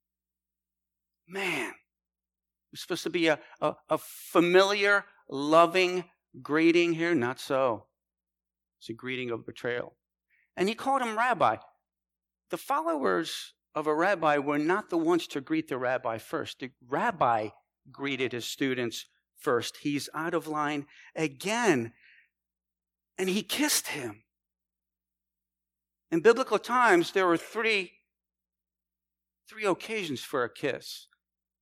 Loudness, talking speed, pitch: -28 LUFS, 125 wpm, 130 Hz